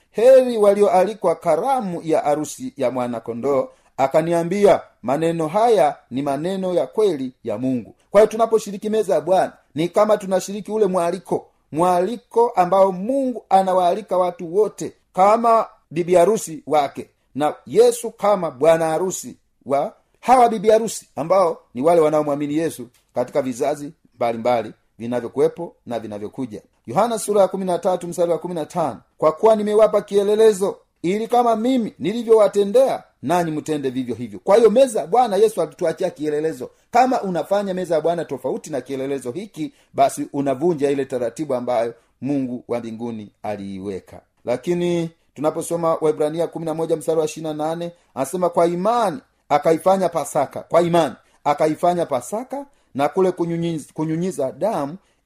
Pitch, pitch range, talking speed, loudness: 170 Hz, 145-205 Hz, 115 wpm, -20 LUFS